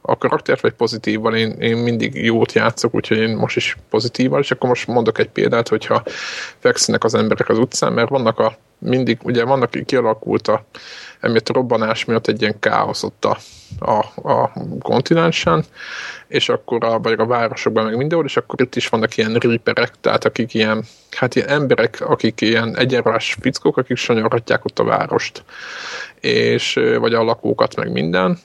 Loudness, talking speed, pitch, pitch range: -17 LUFS, 175 wpm, 115 Hz, 110-120 Hz